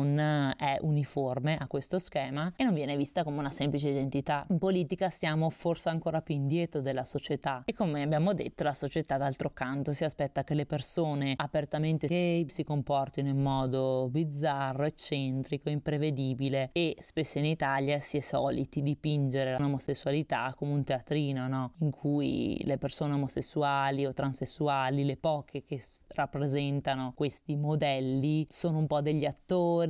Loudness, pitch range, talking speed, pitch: -31 LUFS, 140-155 Hz, 150 wpm, 145 Hz